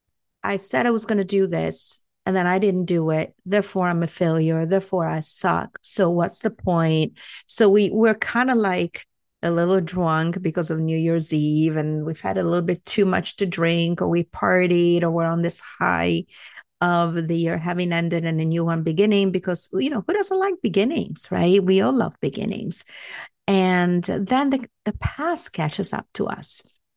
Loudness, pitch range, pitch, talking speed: -21 LUFS, 165-200 Hz, 175 Hz, 195 wpm